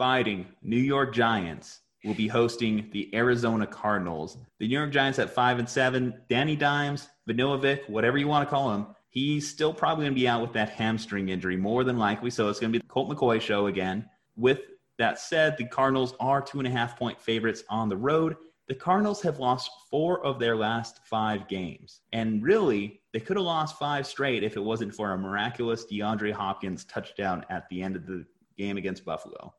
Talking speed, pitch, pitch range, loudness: 200 wpm, 115 Hz, 105-135 Hz, -28 LUFS